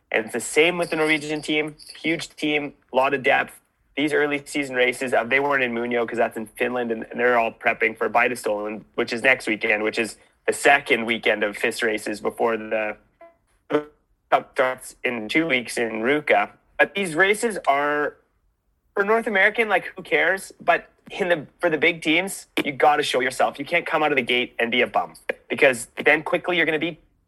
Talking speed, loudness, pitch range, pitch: 200 wpm, -22 LUFS, 120-165 Hz, 145 Hz